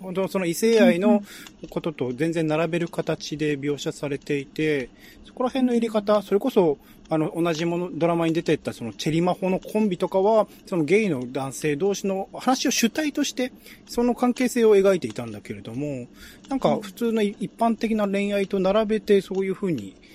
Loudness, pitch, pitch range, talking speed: -24 LUFS, 190 Hz, 155-215 Hz, 365 characters per minute